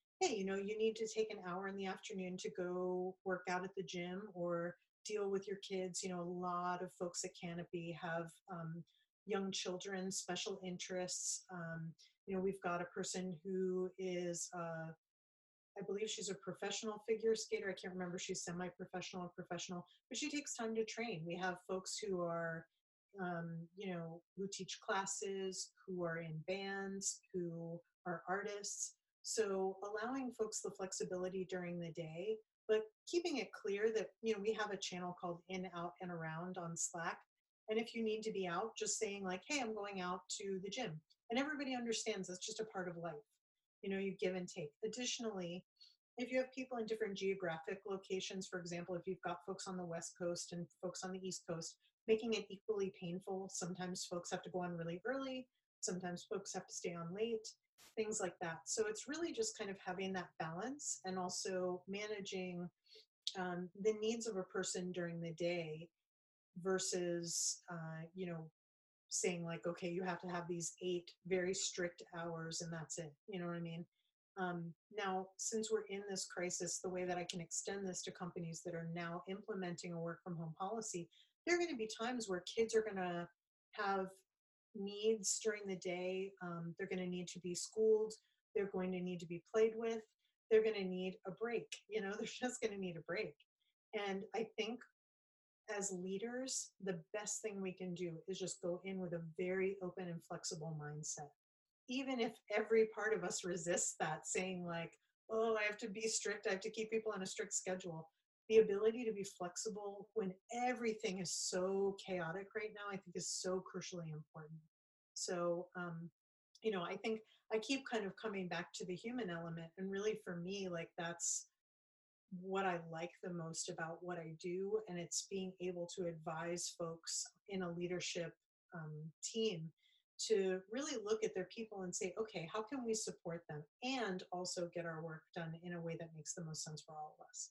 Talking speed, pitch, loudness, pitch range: 195 wpm, 185 Hz, -43 LUFS, 175-215 Hz